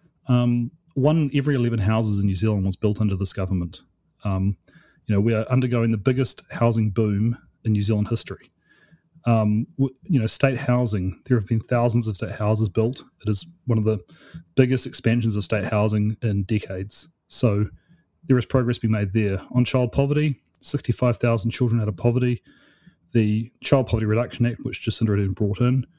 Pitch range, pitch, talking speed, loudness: 105-130 Hz, 115 Hz, 180 wpm, -23 LUFS